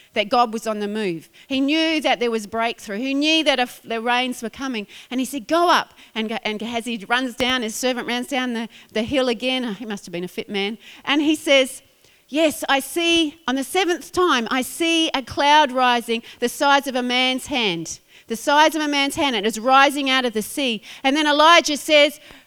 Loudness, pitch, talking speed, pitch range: -20 LUFS, 255 Hz, 230 wpm, 230-290 Hz